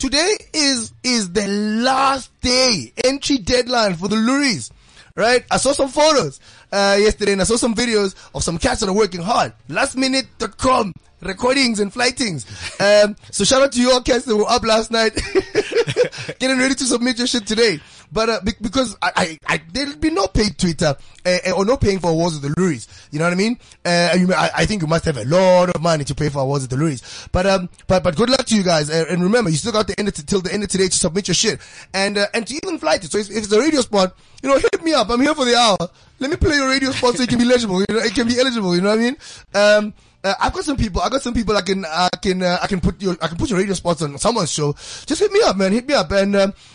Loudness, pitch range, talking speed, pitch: -17 LUFS, 180-250 Hz, 270 wpm, 210 Hz